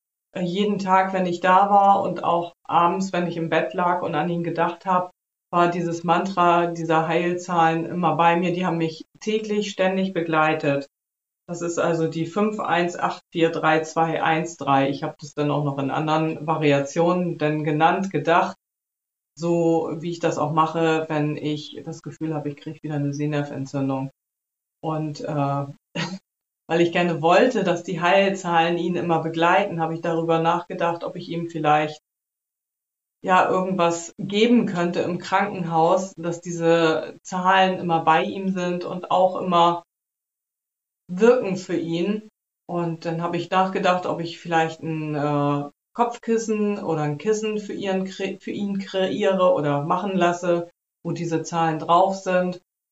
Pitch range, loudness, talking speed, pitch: 160-185 Hz, -22 LUFS, 150 wpm, 170 Hz